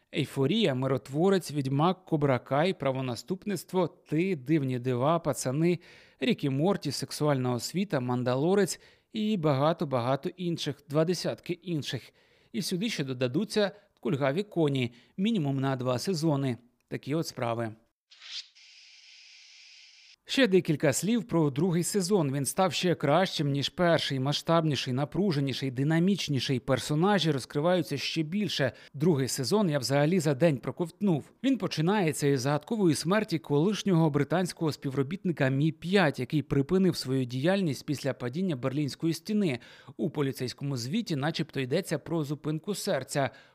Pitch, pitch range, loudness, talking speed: 155 Hz, 135-180 Hz, -29 LUFS, 115 wpm